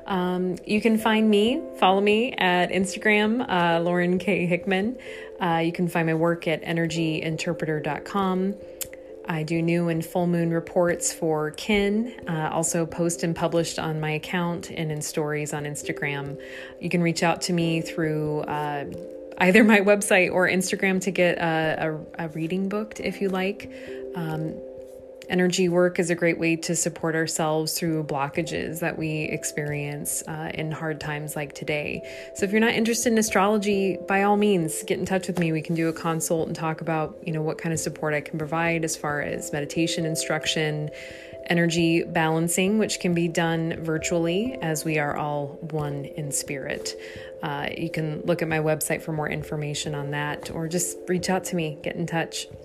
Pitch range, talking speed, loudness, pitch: 155-185 Hz, 180 wpm, -25 LUFS, 170 Hz